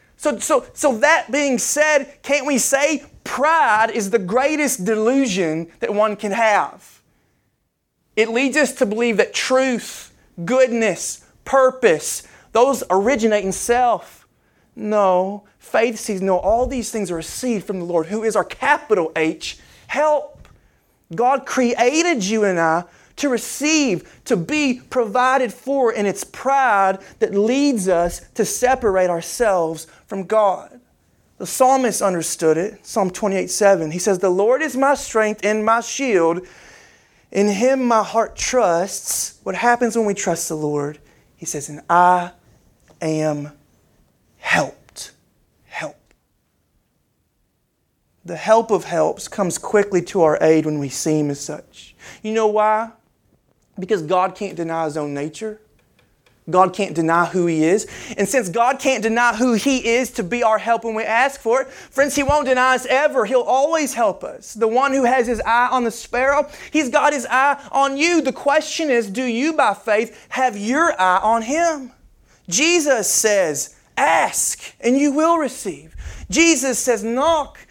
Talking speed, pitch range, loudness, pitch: 155 wpm, 185-265 Hz, -18 LUFS, 225 Hz